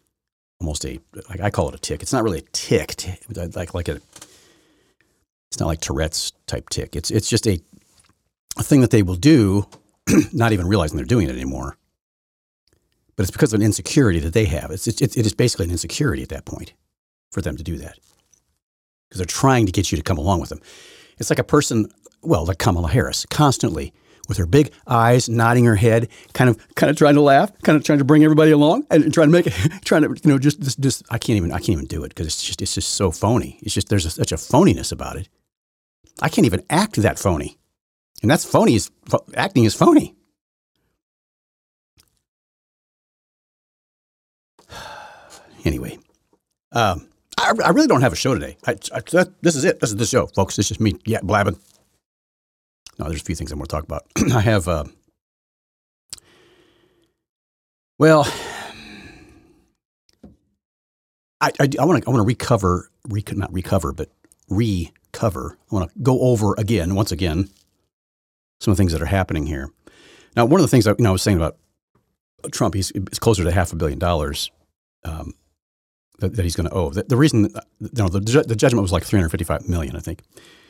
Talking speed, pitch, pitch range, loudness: 200 wpm, 100 Hz, 80-115 Hz, -19 LUFS